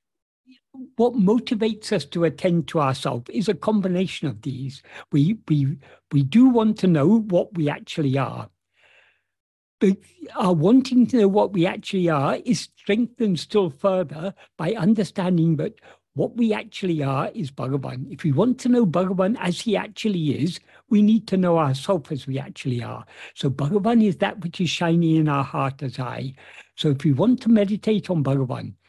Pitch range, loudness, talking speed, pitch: 145-215 Hz, -22 LUFS, 175 wpm, 180 Hz